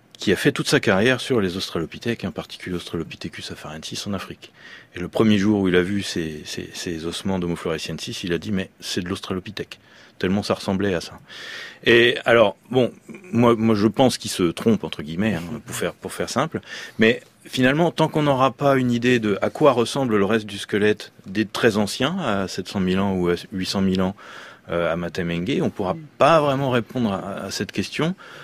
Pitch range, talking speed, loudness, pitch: 95-120 Hz, 205 wpm, -22 LUFS, 105 Hz